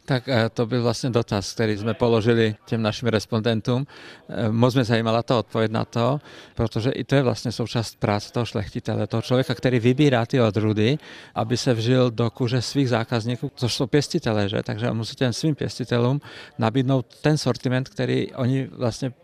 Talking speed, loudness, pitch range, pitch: 170 wpm, -23 LUFS, 115-130 Hz, 120 Hz